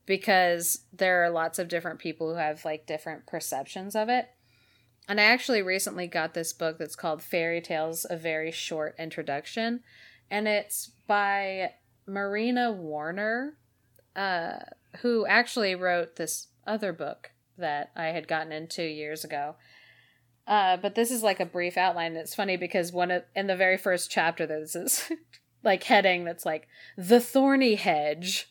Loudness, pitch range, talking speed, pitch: -28 LUFS, 160-205 Hz, 160 wpm, 175 Hz